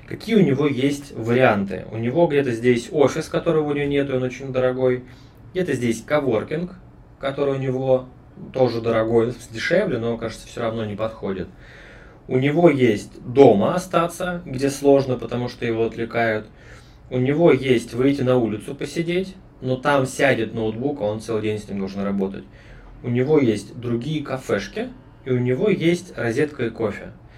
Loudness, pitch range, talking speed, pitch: -21 LUFS, 115-145 Hz, 160 wpm, 130 Hz